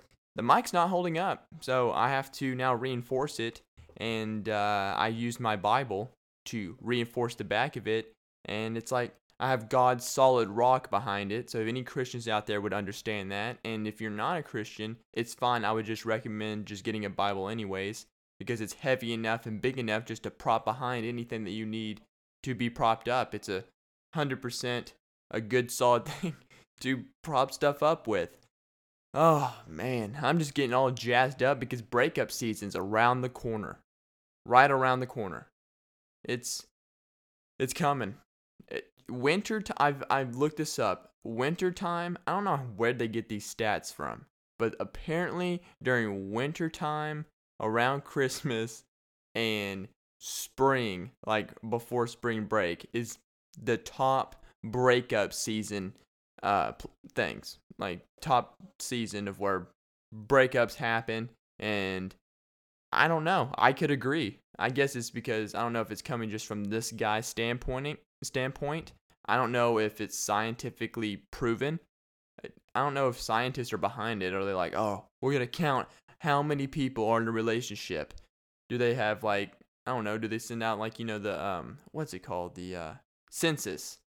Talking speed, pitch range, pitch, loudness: 165 wpm, 110-130 Hz, 115 Hz, -31 LUFS